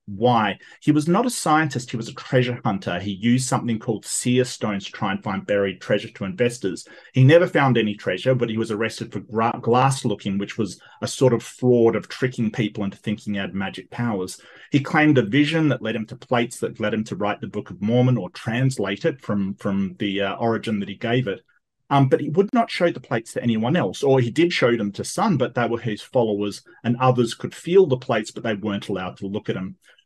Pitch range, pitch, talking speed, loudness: 105-130 Hz, 115 Hz, 240 wpm, -22 LUFS